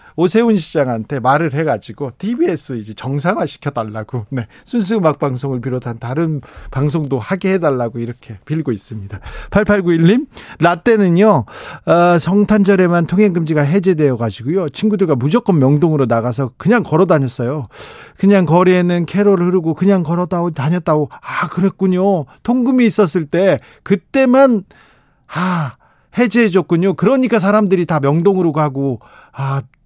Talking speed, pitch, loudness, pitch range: 325 characters per minute, 170 Hz, -15 LUFS, 140-195 Hz